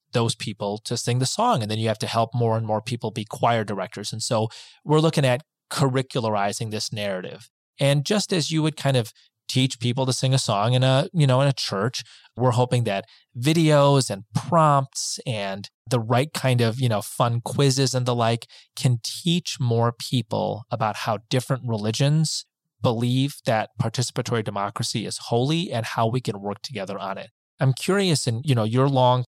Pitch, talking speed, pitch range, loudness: 125 Hz, 190 wpm, 115-135 Hz, -23 LUFS